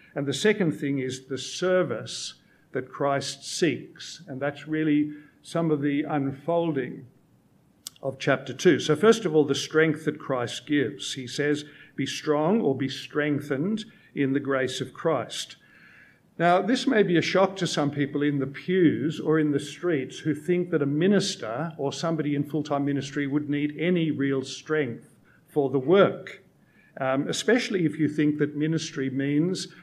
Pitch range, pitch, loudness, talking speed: 140-165 Hz, 150 Hz, -26 LUFS, 170 wpm